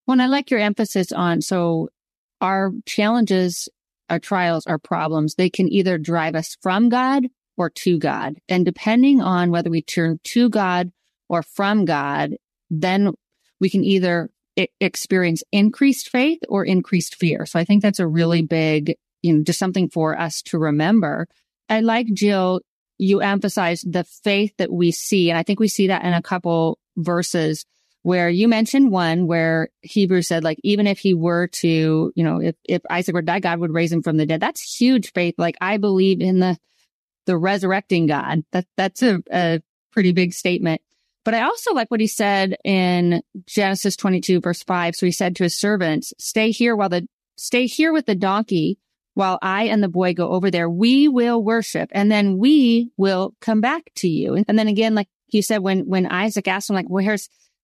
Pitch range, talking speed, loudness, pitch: 170-210 Hz, 195 wpm, -19 LUFS, 185 Hz